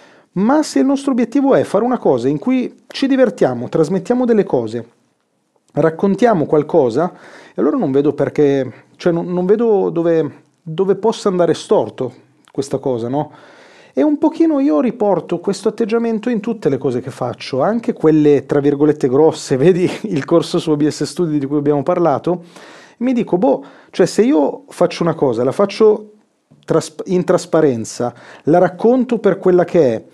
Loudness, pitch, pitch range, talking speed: -16 LUFS, 180 Hz, 150-230 Hz, 160 wpm